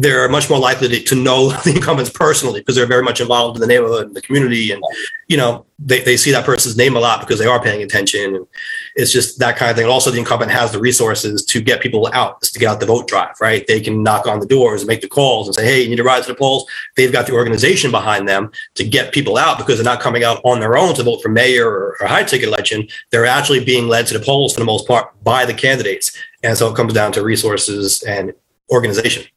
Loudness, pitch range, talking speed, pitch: -14 LUFS, 120-175 Hz, 265 wpm, 125 Hz